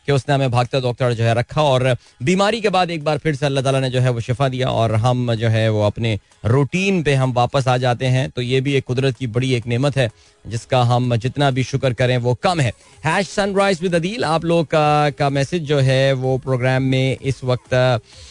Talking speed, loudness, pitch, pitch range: 235 wpm, -18 LUFS, 130 Hz, 125-145 Hz